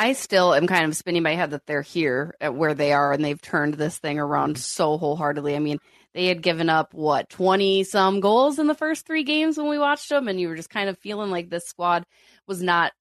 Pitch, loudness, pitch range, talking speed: 175 Hz, -23 LUFS, 150-205 Hz, 250 wpm